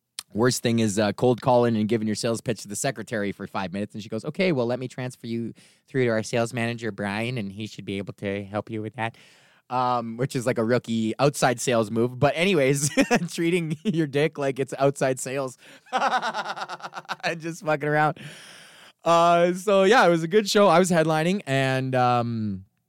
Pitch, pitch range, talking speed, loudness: 125 Hz, 110-150 Hz, 200 wpm, -24 LUFS